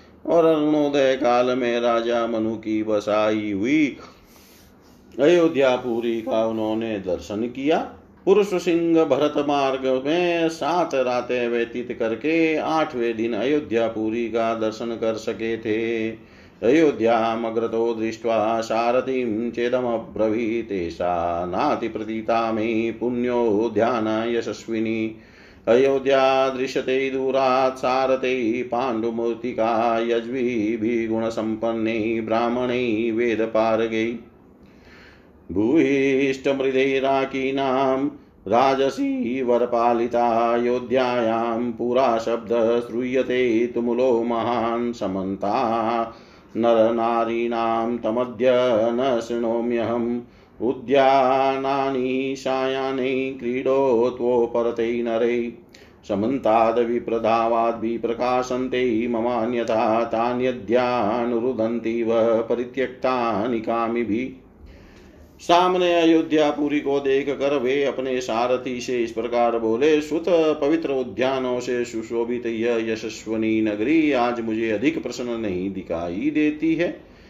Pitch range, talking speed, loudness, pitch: 115-130 Hz, 80 wpm, -22 LUFS, 120 Hz